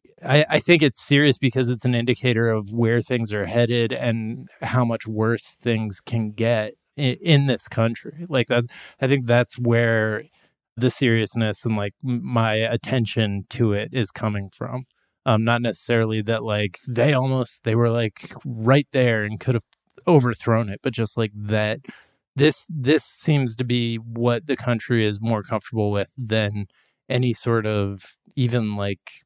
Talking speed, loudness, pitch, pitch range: 165 wpm, -22 LUFS, 115 Hz, 110-125 Hz